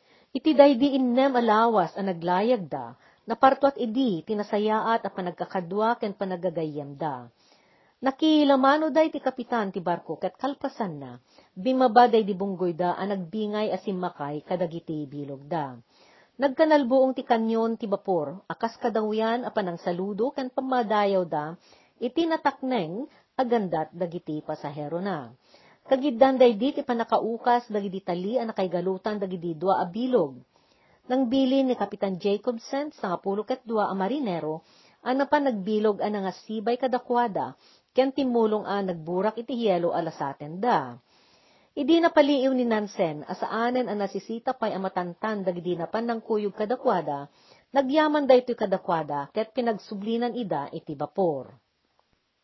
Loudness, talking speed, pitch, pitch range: -26 LUFS, 135 wpm, 215 Hz, 180-250 Hz